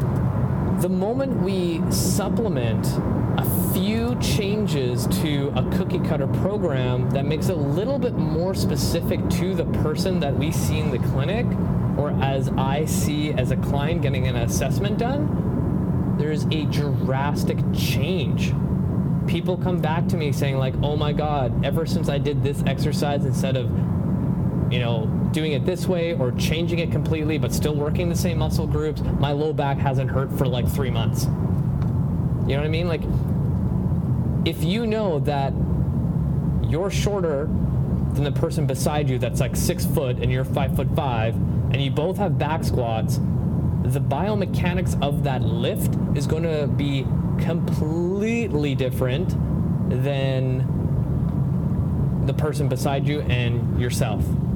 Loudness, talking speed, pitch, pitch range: -22 LUFS, 150 wpm, 150 Hz, 135-165 Hz